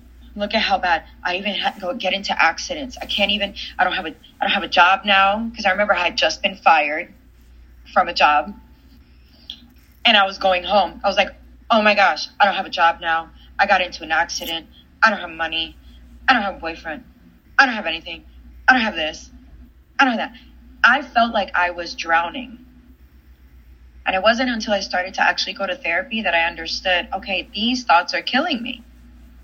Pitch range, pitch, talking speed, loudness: 160-205 Hz, 180 Hz, 215 wpm, -19 LUFS